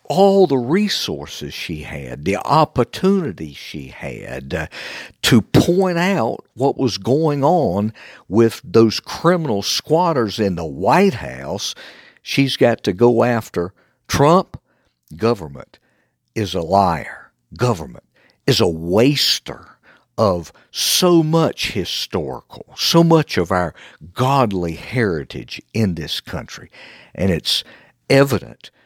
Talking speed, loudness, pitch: 115 wpm, -18 LUFS, 120 Hz